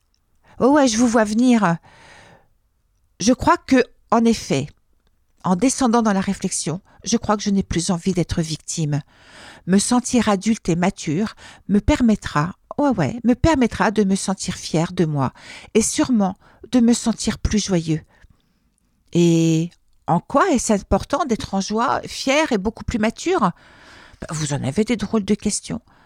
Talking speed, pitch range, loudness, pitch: 160 wpm, 170-235 Hz, -20 LUFS, 210 Hz